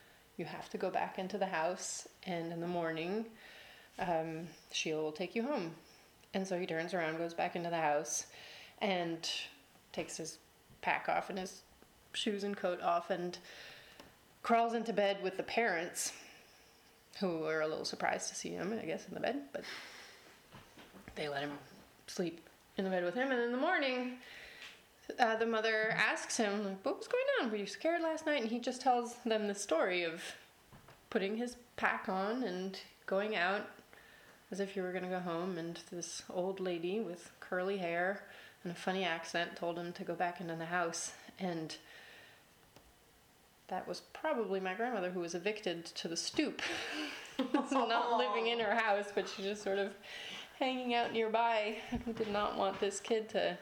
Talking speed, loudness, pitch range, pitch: 180 wpm, -37 LUFS, 175-225 Hz, 195 Hz